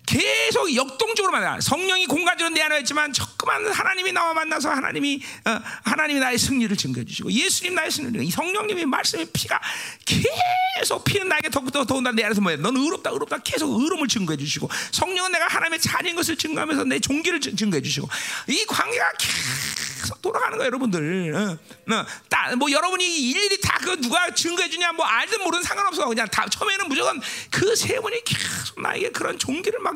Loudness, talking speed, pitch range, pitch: -22 LUFS, 415 characters per minute, 260-375 Hz, 320 Hz